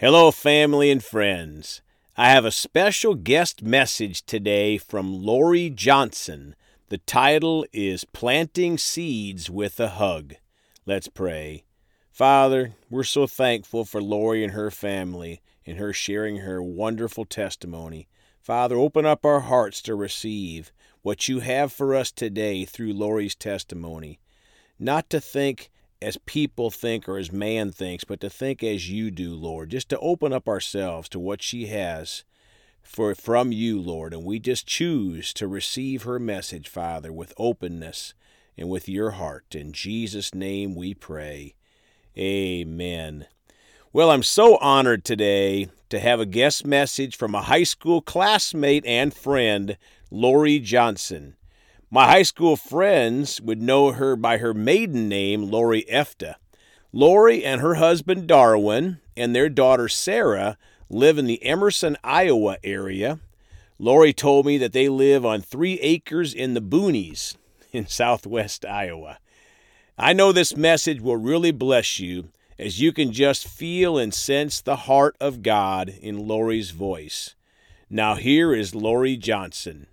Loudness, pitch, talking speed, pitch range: -21 LUFS, 110 Hz, 145 wpm, 95-140 Hz